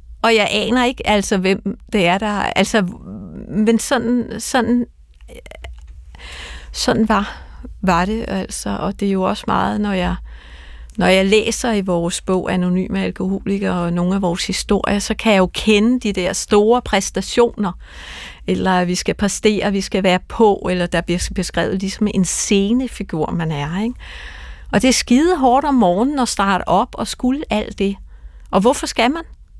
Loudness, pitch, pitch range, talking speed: -17 LUFS, 200 Hz, 180-225 Hz, 175 wpm